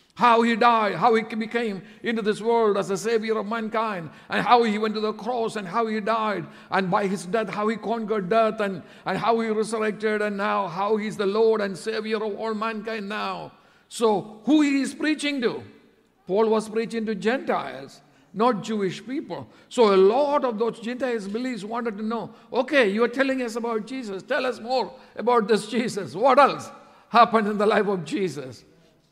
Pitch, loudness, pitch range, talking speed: 220 Hz, -24 LUFS, 210-235 Hz, 195 wpm